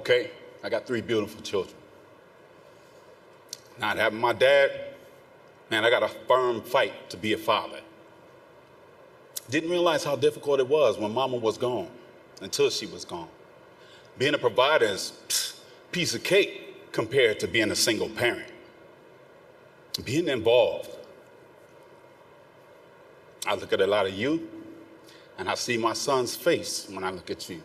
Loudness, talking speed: -26 LUFS, 145 wpm